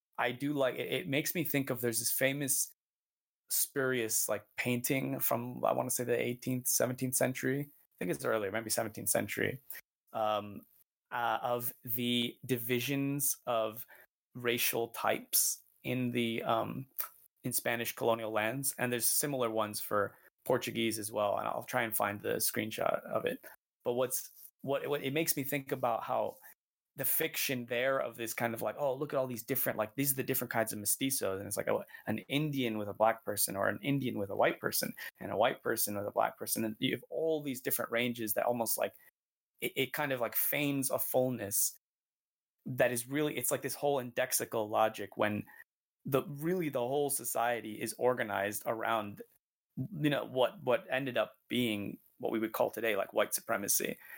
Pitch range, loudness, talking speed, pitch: 115-135 Hz, -33 LUFS, 190 wpm, 120 Hz